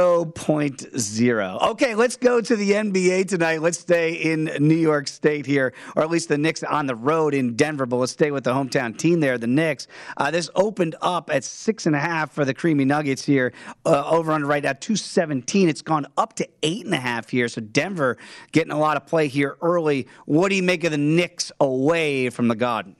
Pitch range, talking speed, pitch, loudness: 135-170 Hz, 205 wpm, 155 Hz, -22 LUFS